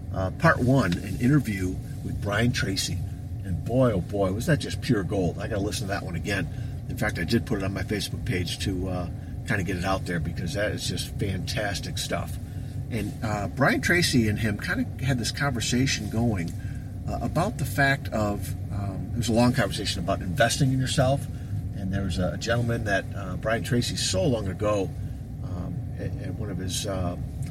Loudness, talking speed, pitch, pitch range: -27 LUFS, 205 wpm, 105 Hz, 95-120 Hz